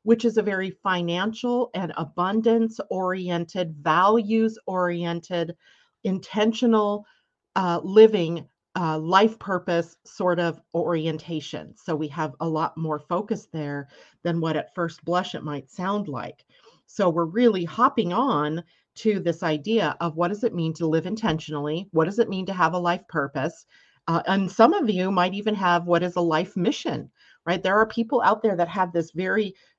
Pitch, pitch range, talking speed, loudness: 180 Hz, 165-215 Hz, 170 wpm, -24 LUFS